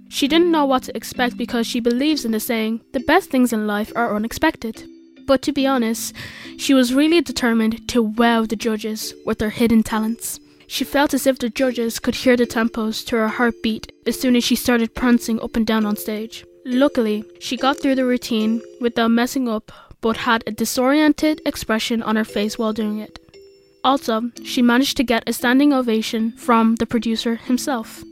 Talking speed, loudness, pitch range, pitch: 195 wpm, -19 LUFS, 225-260 Hz, 235 Hz